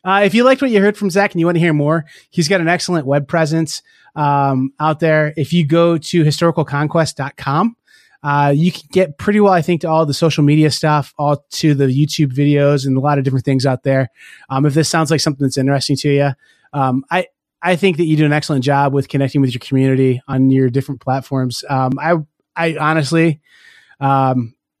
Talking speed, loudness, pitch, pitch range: 220 wpm, -15 LUFS, 150 Hz, 135-165 Hz